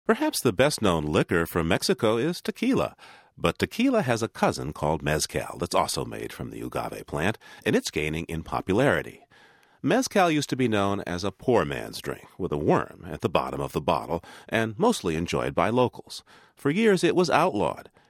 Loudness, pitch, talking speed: -26 LUFS, 115 Hz, 190 wpm